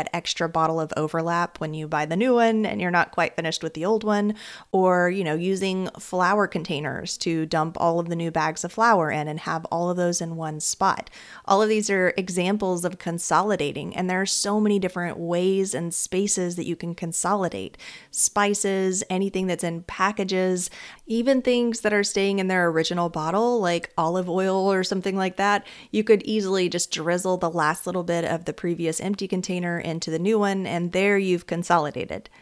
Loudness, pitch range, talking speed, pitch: -24 LUFS, 170-195 Hz, 200 wpm, 180 Hz